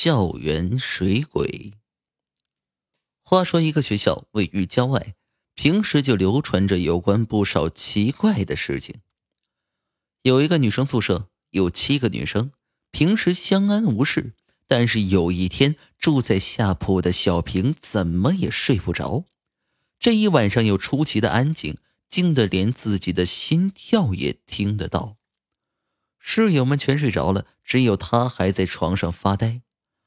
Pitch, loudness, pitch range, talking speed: 110 Hz, -21 LUFS, 95-140 Hz, 205 characters per minute